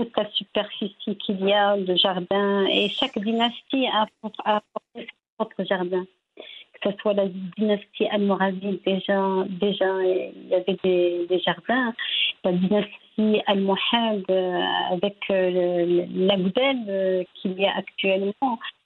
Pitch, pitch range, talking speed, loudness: 200 Hz, 185-215 Hz, 130 wpm, -23 LUFS